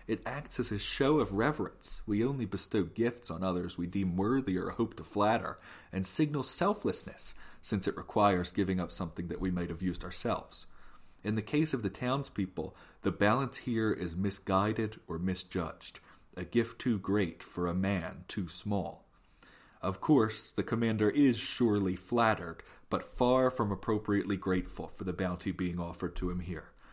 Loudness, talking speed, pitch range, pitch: -33 LUFS, 170 wpm, 90-115 Hz, 100 Hz